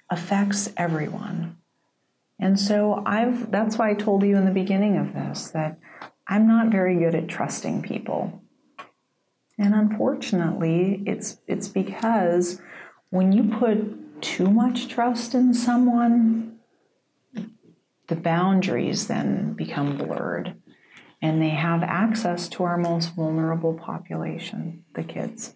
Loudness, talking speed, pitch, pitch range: -23 LUFS, 120 wpm, 195 Hz, 175-220 Hz